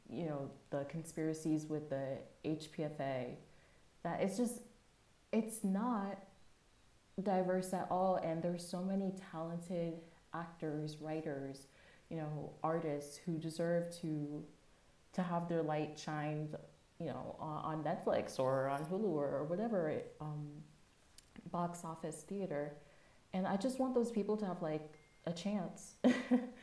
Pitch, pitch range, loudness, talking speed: 165 Hz, 150-190 Hz, -40 LUFS, 130 wpm